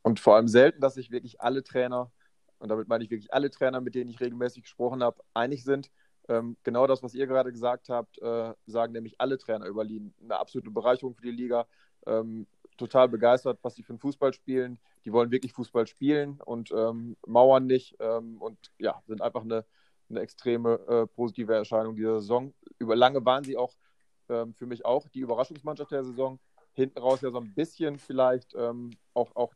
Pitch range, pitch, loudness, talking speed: 115-130 Hz, 125 Hz, -28 LUFS, 195 wpm